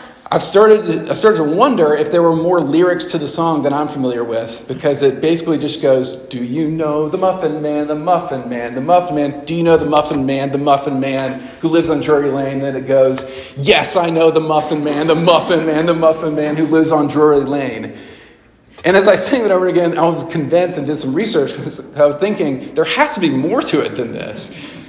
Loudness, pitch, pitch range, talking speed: -15 LUFS, 150 Hz, 140-165 Hz, 235 wpm